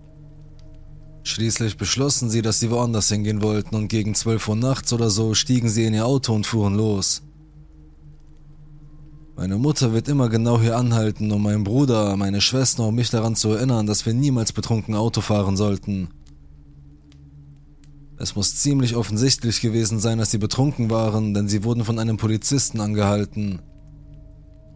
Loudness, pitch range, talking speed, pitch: -20 LUFS, 105-120 Hz, 155 wpm, 110 Hz